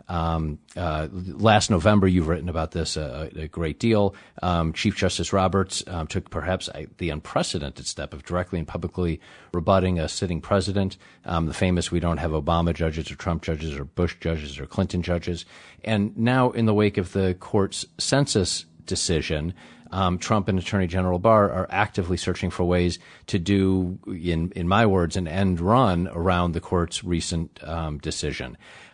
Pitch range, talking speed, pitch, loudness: 80-95 Hz, 175 wpm, 90 Hz, -24 LUFS